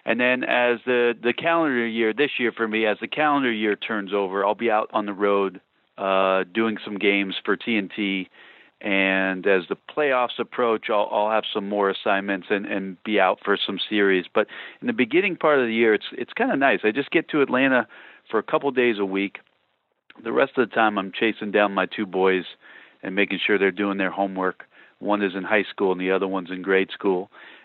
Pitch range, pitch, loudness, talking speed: 95-115 Hz, 105 Hz, -22 LUFS, 220 wpm